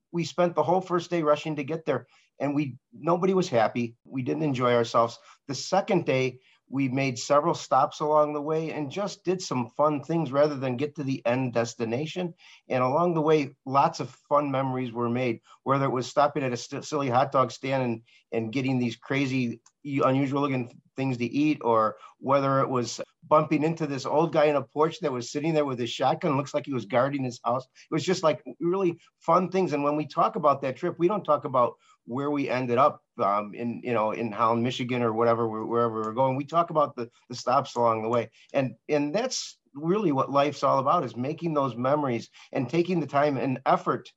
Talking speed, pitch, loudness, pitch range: 215 wpm, 140 Hz, -26 LUFS, 125-155 Hz